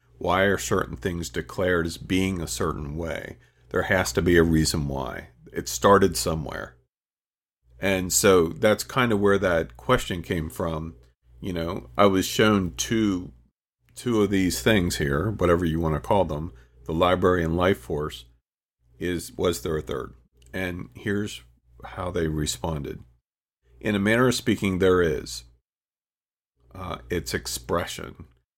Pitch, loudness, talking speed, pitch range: 85 Hz, -24 LUFS, 150 wpm, 75-100 Hz